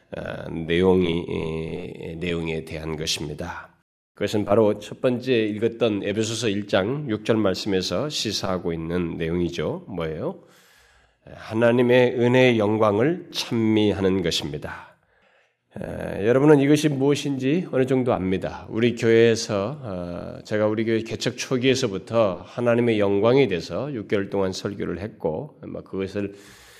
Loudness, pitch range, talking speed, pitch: -23 LUFS, 95-125 Hz, 290 characters per minute, 105 Hz